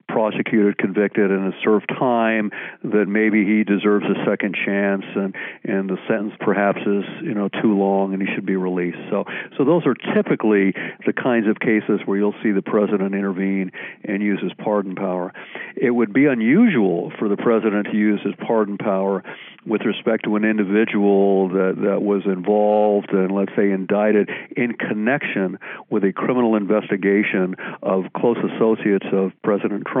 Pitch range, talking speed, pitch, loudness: 100-110 Hz, 170 wpm, 105 Hz, -20 LUFS